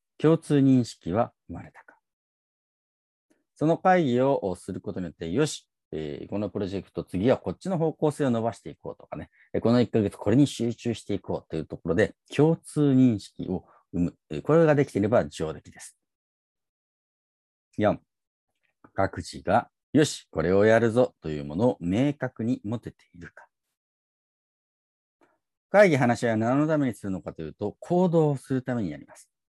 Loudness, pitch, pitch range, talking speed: -26 LUFS, 120 Hz, 95-145 Hz, 310 characters per minute